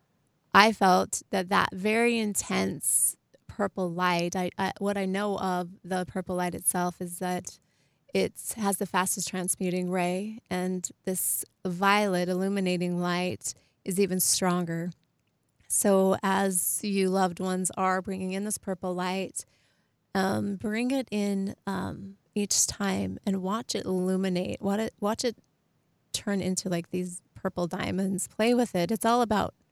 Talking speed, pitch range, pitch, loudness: 140 wpm, 180-200 Hz, 190 Hz, -28 LUFS